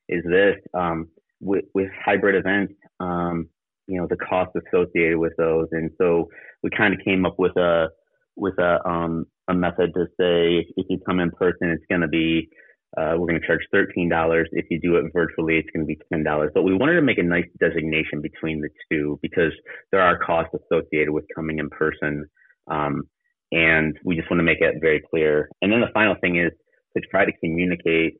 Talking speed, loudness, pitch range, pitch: 210 wpm, -22 LUFS, 80-85 Hz, 85 Hz